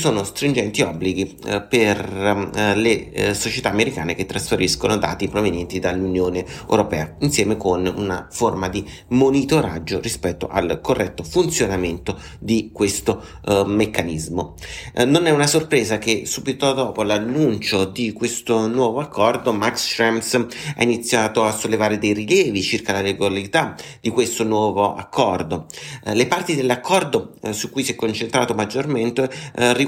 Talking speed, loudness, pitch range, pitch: 140 wpm, -20 LUFS, 95-120 Hz, 105 Hz